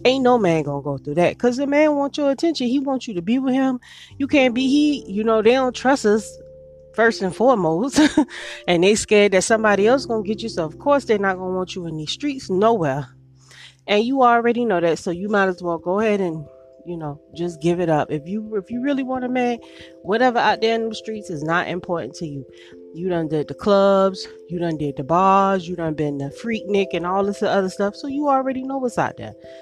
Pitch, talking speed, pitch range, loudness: 200 Hz, 245 wpm, 165-245 Hz, -20 LUFS